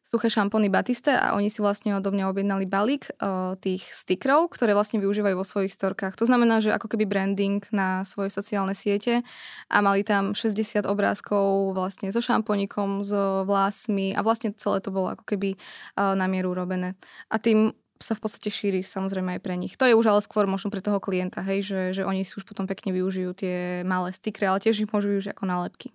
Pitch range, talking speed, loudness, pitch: 190-215 Hz, 200 wpm, -25 LUFS, 200 Hz